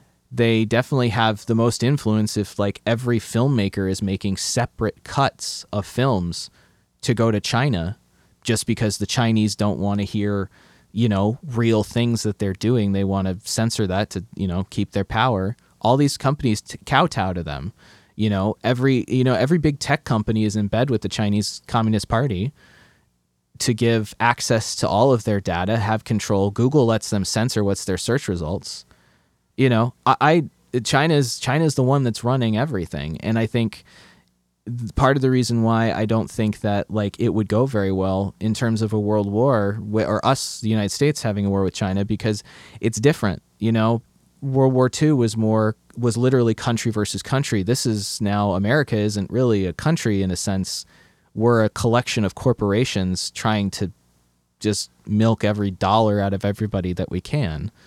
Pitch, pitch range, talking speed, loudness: 110 Hz, 100-120 Hz, 185 wpm, -21 LUFS